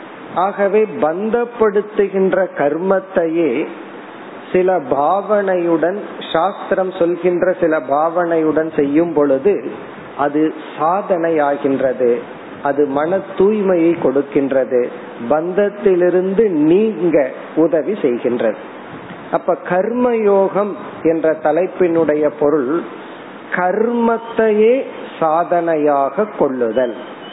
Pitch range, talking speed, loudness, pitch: 155-200 Hz, 60 wpm, -16 LUFS, 180 Hz